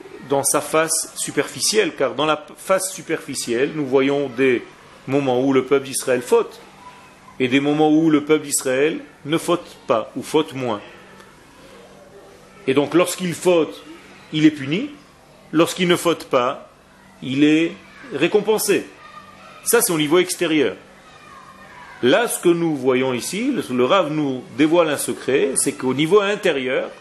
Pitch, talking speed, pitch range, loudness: 155 Hz, 145 wpm, 140-175 Hz, -19 LUFS